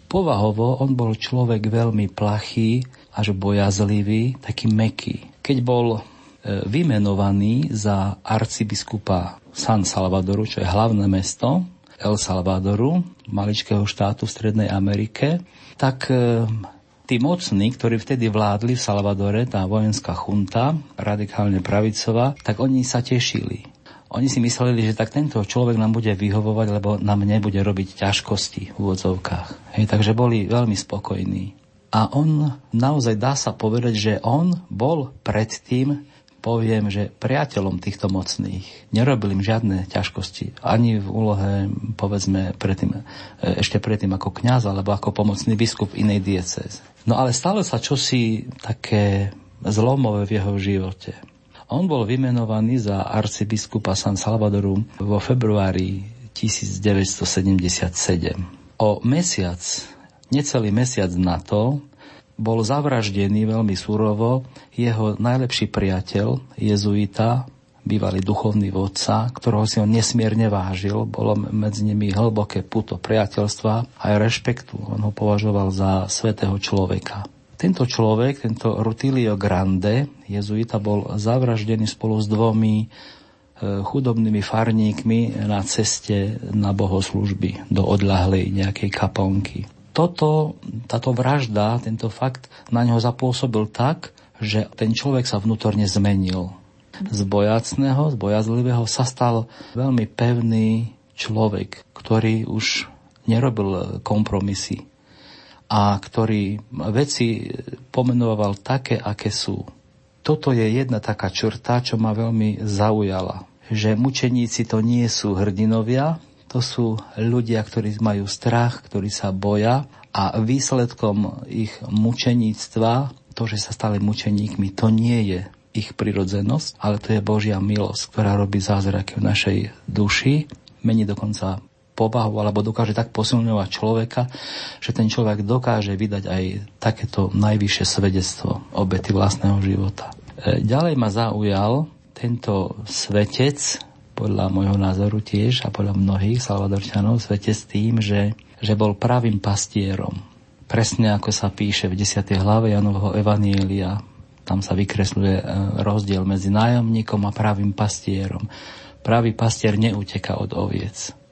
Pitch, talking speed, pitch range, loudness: 110 Hz, 120 wpm, 100-120 Hz, -21 LUFS